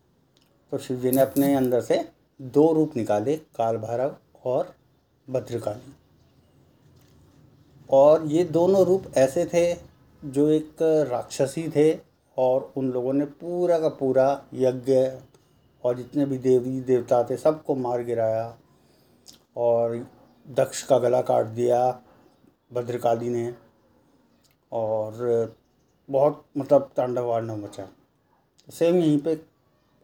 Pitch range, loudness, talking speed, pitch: 120-150 Hz, -24 LUFS, 115 wpm, 130 Hz